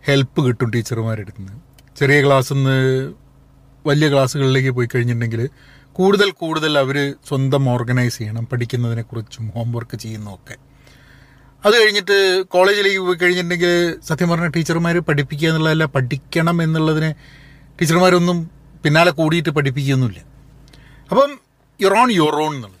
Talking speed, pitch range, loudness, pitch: 110 wpm, 130-165 Hz, -17 LUFS, 140 Hz